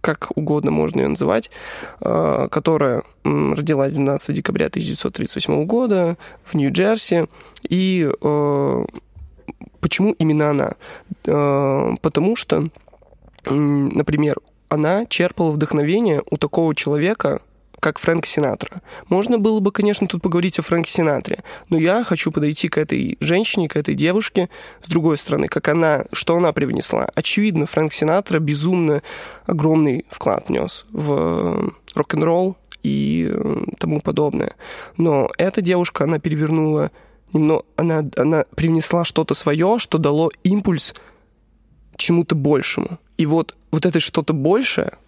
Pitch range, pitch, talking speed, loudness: 150-180 Hz, 160 Hz, 120 wpm, -19 LUFS